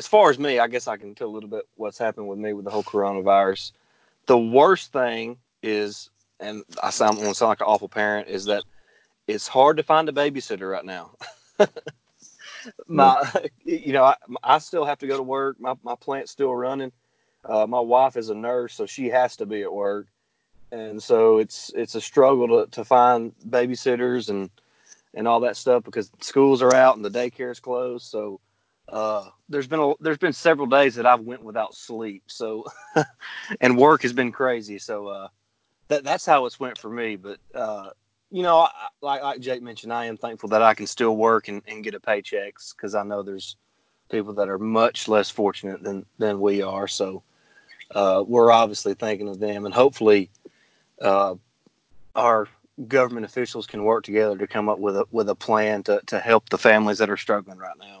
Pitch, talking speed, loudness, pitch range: 115 Hz, 200 wpm, -22 LUFS, 105-125 Hz